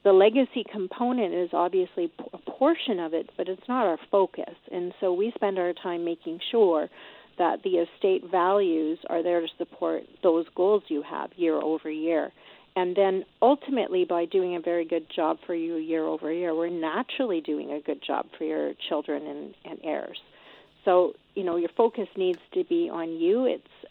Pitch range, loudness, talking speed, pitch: 170-245 Hz, -27 LUFS, 185 wpm, 185 Hz